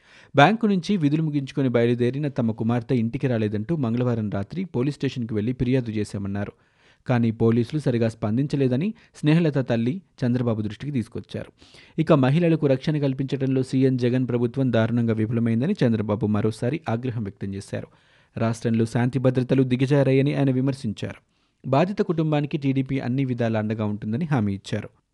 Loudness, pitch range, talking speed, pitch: -23 LUFS, 115-140 Hz, 130 wpm, 125 Hz